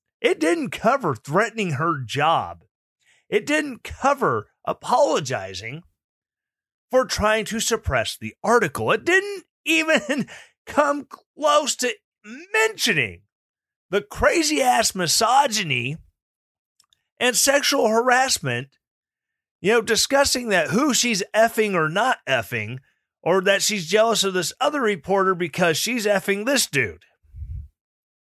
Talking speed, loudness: 110 wpm, -21 LUFS